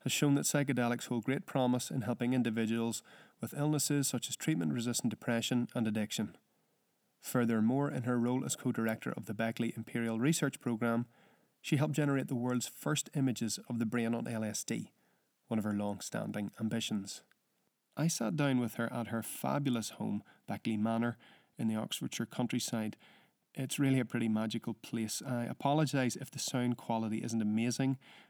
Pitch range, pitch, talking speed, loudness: 115-130 Hz, 120 Hz, 170 wpm, -35 LUFS